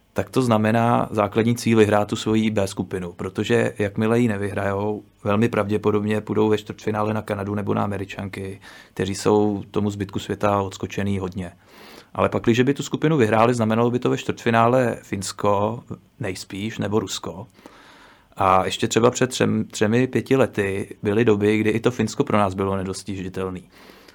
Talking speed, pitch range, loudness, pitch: 160 wpm, 100-115 Hz, -22 LUFS, 105 Hz